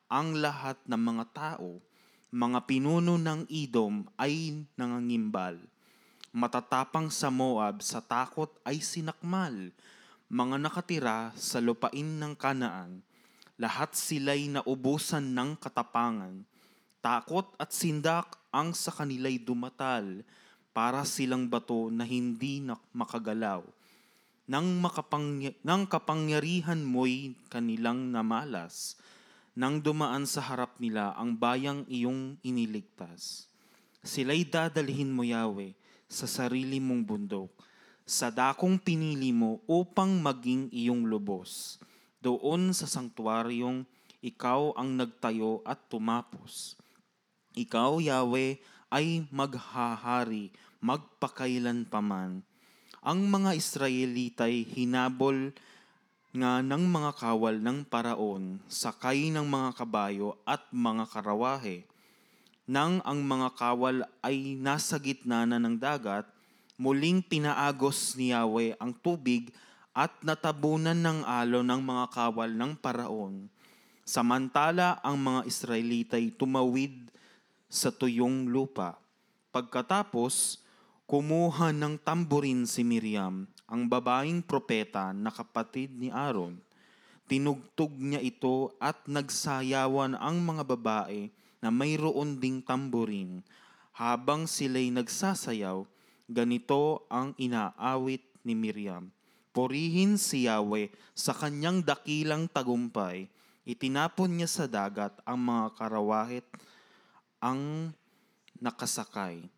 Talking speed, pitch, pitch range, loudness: 100 wpm, 130 Hz, 120-150 Hz, -31 LUFS